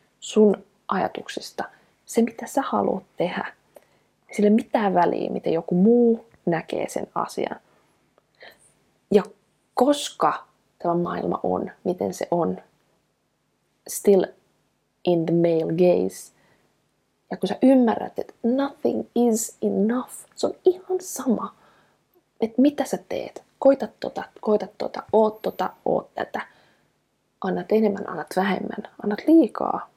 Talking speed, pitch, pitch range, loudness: 120 wpm, 215 Hz, 190-250 Hz, -23 LUFS